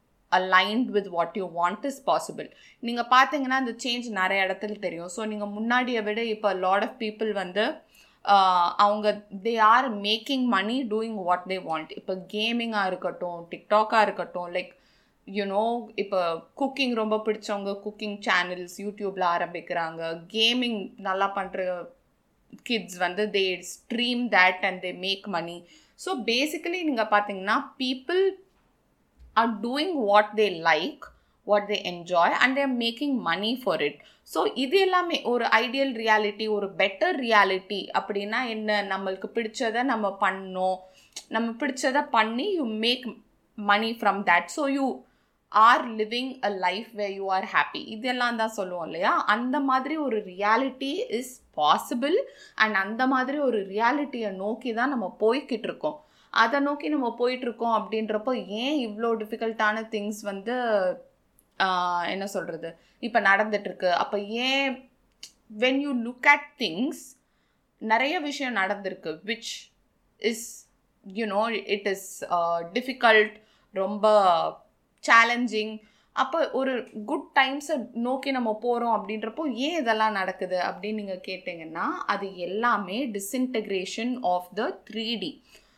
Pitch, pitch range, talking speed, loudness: 220 Hz, 195-250 Hz, 130 wpm, -26 LUFS